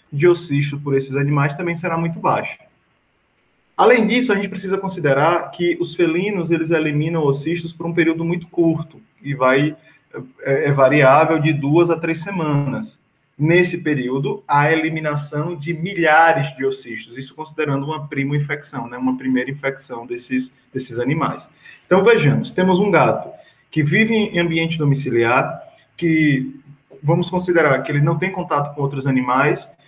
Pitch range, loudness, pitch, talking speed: 140-170 Hz, -18 LUFS, 155 Hz, 155 wpm